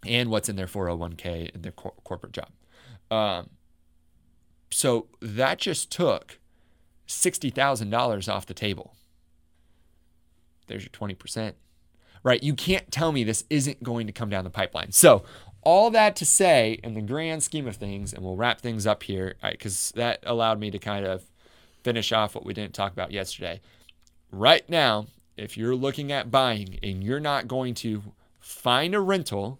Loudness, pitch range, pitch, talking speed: -25 LUFS, 90-125 Hz, 105 Hz, 175 wpm